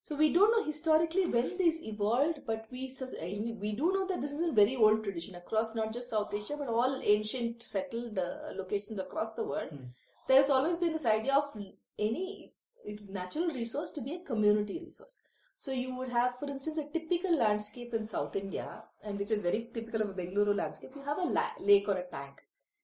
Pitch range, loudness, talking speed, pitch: 210-295 Hz, -32 LUFS, 200 wpm, 230 Hz